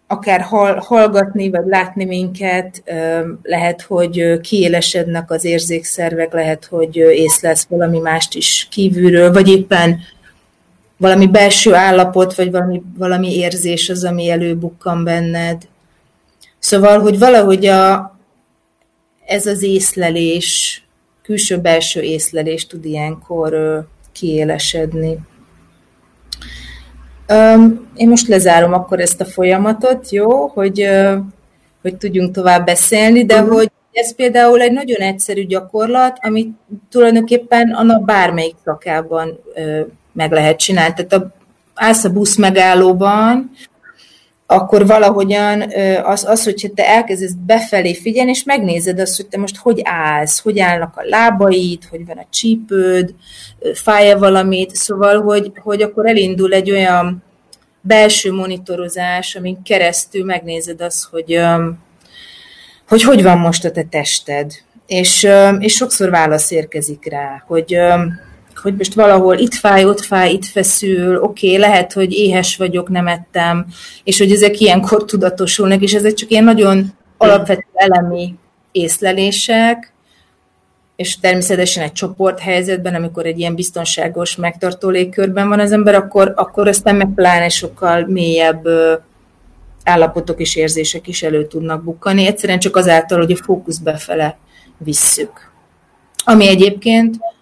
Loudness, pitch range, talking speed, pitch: -12 LUFS, 170-205 Hz, 125 wpm, 185 Hz